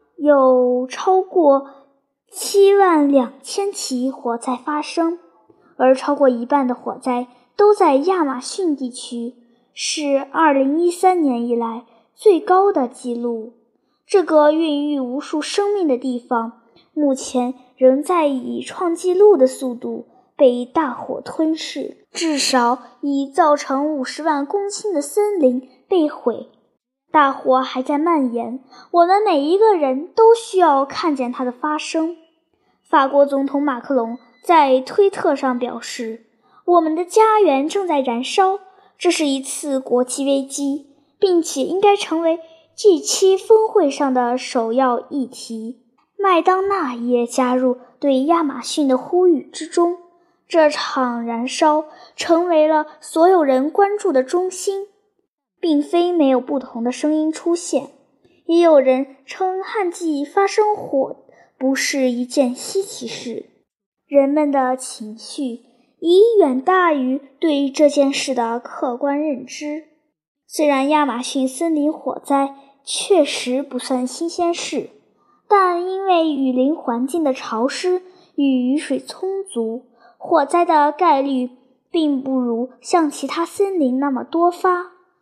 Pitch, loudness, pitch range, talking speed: 290 Hz, -18 LUFS, 255-345 Hz, 190 characters per minute